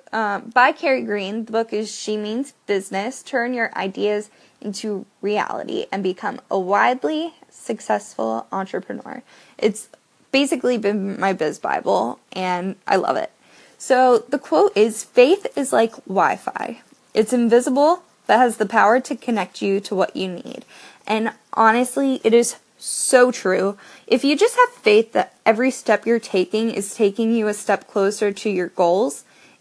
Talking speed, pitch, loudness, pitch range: 160 wpm, 220 Hz, -20 LUFS, 200-255 Hz